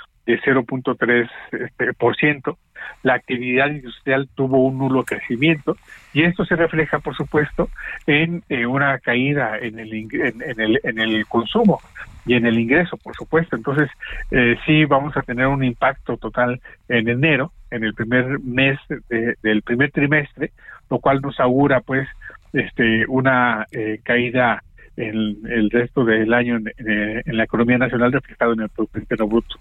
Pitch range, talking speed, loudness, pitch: 115-140 Hz, 165 wpm, -19 LUFS, 125 Hz